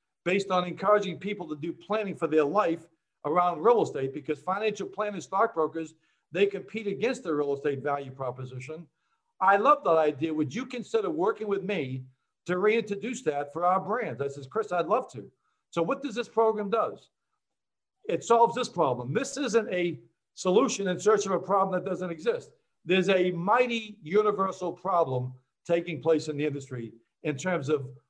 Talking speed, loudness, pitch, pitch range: 175 wpm, -28 LUFS, 180 Hz, 155-215 Hz